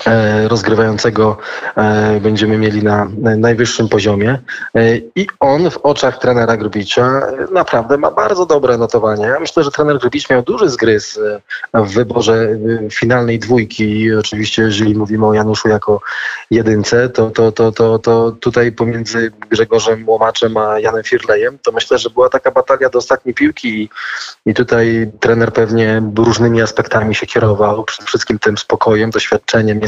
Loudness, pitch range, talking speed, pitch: -13 LUFS, 110-120 Hz, 145 wpm, 115 Hz